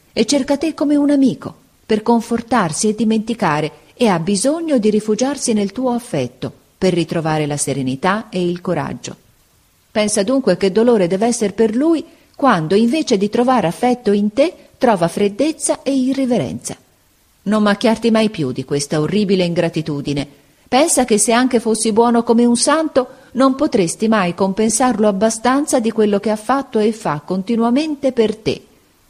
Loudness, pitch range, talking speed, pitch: -16 LUFS, 185-255 Hz, 155 wpm, 225 Hz